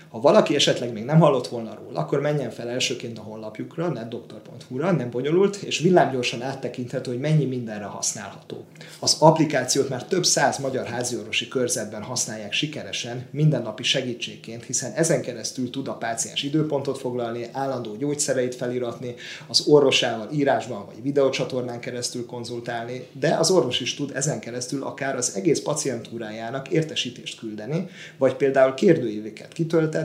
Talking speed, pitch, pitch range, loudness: 140 wpm, 125 Hz, 120-145 Hz, -23 LUFS